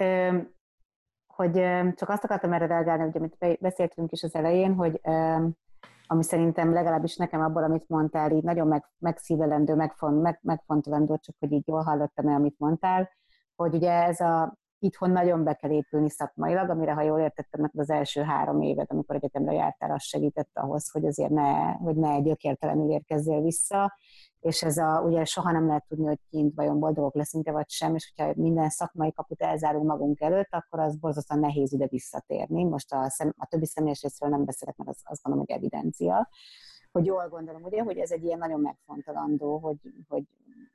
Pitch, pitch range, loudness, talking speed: 160 Hz, 150-170 Hz, -27 LUFS, 185 wpm